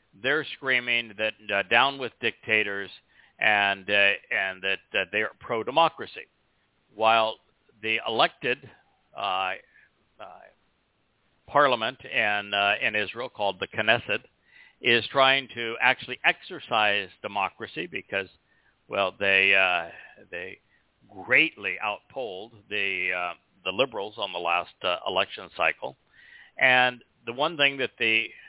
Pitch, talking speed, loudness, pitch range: 110 Hz, 120 wpm, -25 LUFS, 100-120 Hz